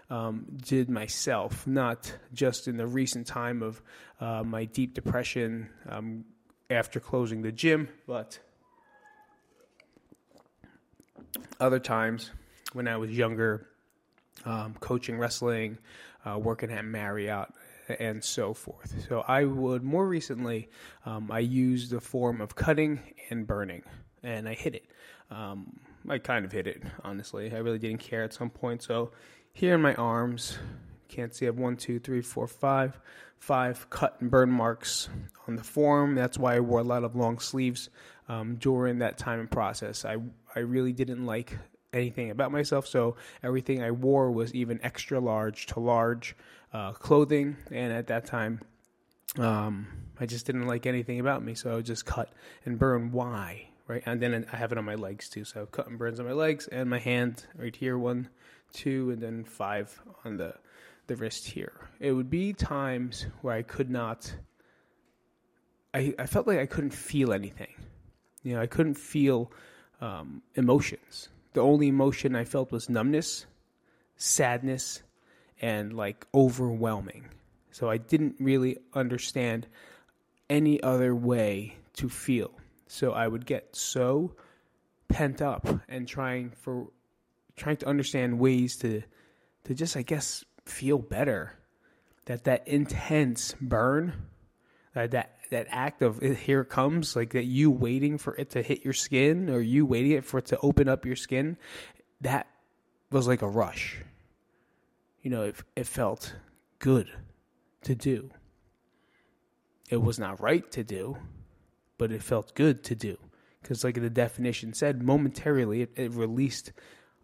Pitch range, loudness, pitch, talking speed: 115-135 Hz, -30 LUFS, 120 Hz, 160 wpm